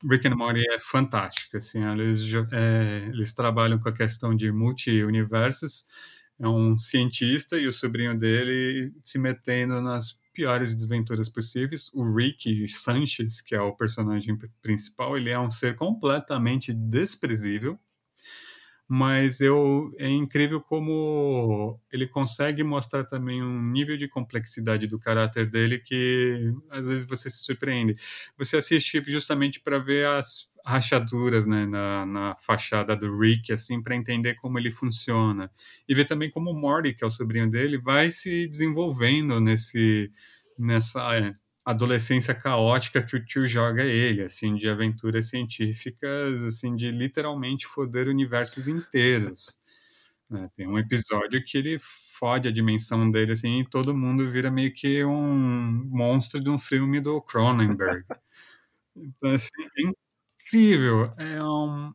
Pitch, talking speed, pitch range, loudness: 125 Hz, 140 wpm, 115-140 Hz, -25 LUFS